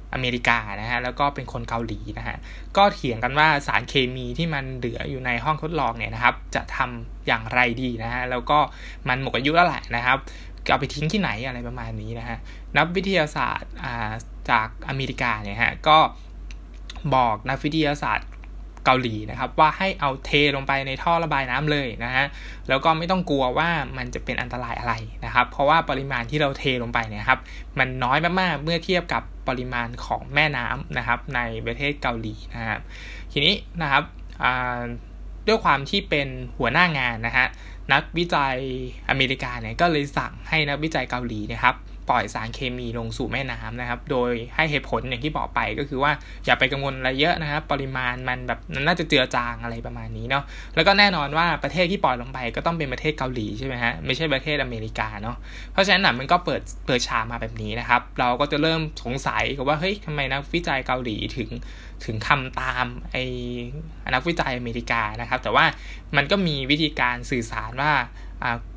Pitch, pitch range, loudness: 130 Hz, 115-145 Hz, -23 LUFS